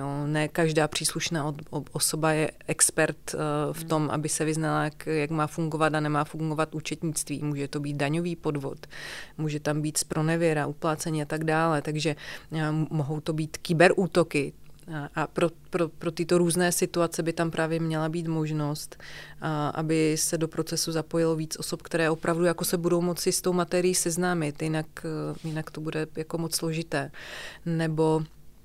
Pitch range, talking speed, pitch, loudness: 155-165 Hz, 155 wpm, 160 Hz, -27 LUFS